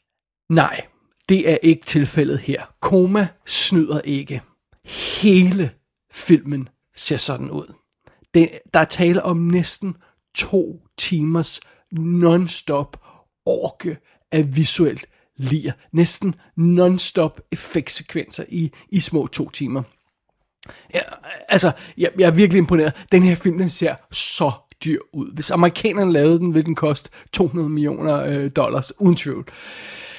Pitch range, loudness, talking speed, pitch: 150-180 Hz, -19 LUFS, 120 wpm, 165 Hz